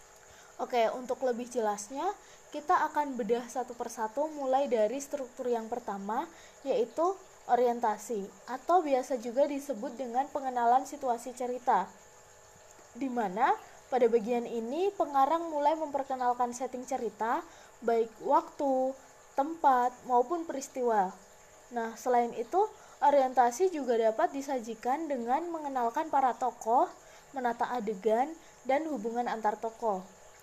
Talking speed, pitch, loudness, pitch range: 110 wpm, 255 Hz, -31 LUFS, 240-285 Hz